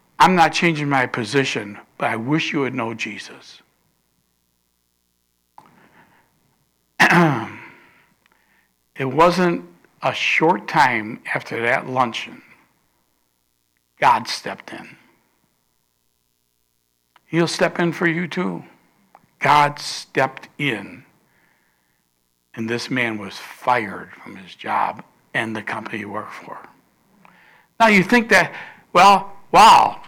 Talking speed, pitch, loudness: 105 wpm, 120 Hz, -18 LUFS